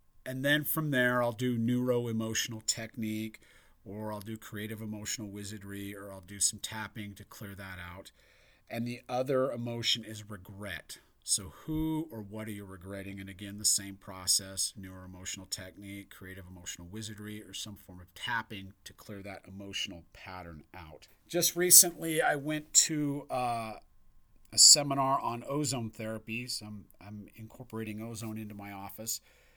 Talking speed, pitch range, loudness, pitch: 160 wpm, 100-120 Hz, -29 LUFS, 105 Hz